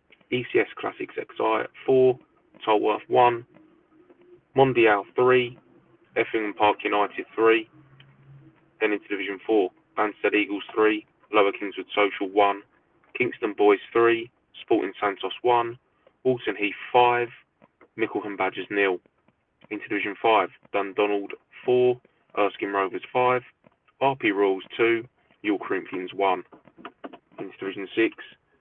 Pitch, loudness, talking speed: 125 Hz, -24 LUFS, 110 wpm